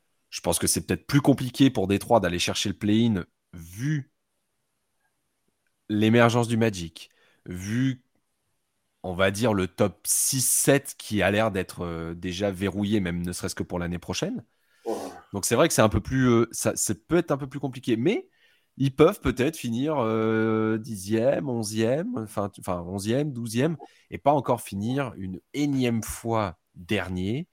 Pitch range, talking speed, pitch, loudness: 100-130 Hz, 160 wpm, 110 Hz, -25 LUFS